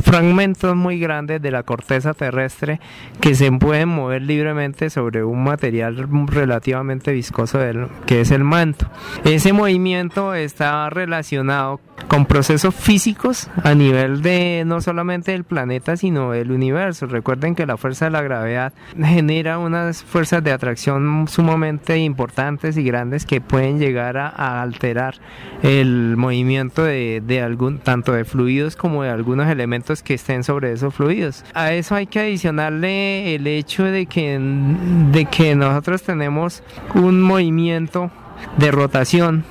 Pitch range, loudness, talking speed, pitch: 130-170 Hz, -18 LUFS, 145 wpm, 150 Hz